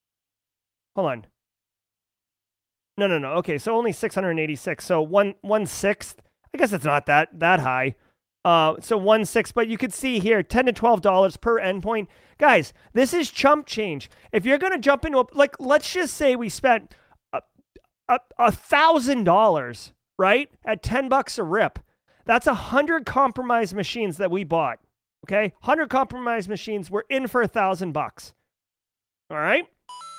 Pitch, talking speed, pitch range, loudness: 215 Hz, 165 wpm, 155-255 Hz, -22 LUFS